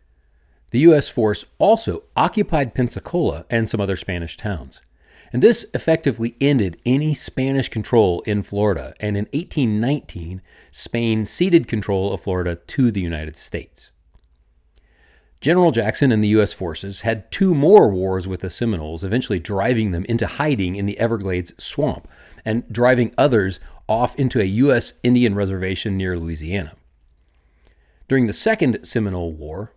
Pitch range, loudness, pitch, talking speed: 85-125 Hz, -19 LUFS, 105 Hz, 140 wpm